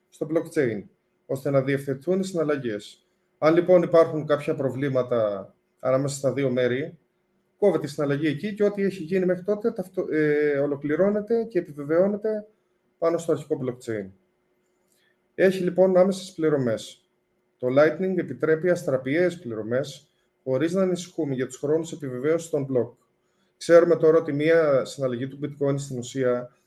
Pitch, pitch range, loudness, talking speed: 155 Hz, 135-180 Hz, -24 LUFS, 135 wpm